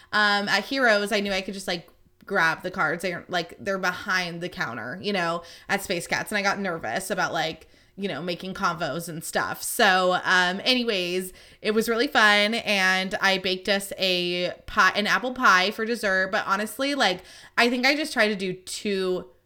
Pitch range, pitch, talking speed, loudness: 180-210 Hz, 195 Hz, 195 wpm, -24 LUFS